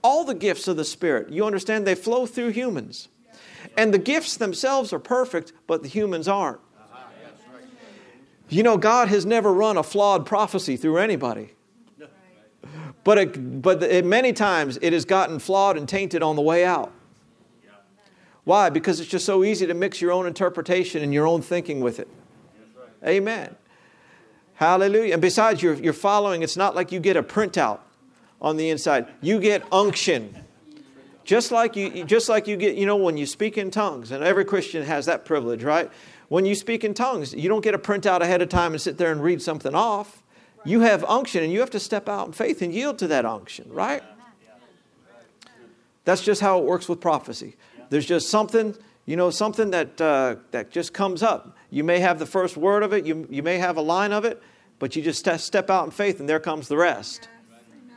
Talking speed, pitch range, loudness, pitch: 200 wpm, 170-215 Hz, -22 LUFS, 190 Hz